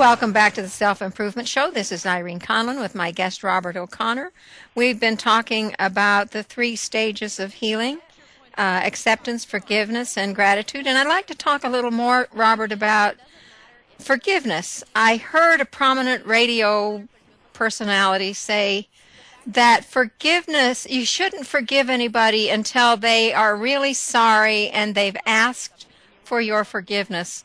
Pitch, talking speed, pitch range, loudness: 225 Hz, 140 wpm, 205-250 Hz, -19 LUFS